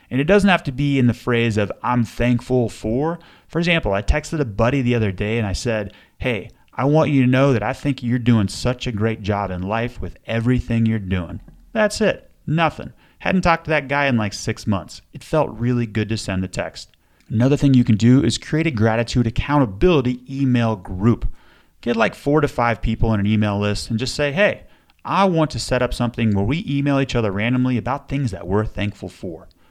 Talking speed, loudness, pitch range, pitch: 220 wpm, -20 LUFS, 105-140 Hz, 120 Hz